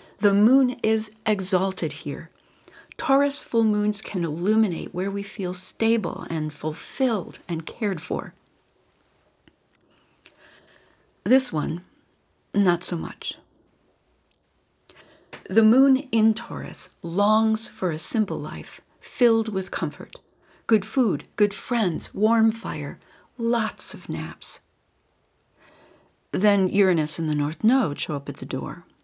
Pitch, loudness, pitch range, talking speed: 210 Hz, -23 LUFS, 175-225 Hz, 115 wpm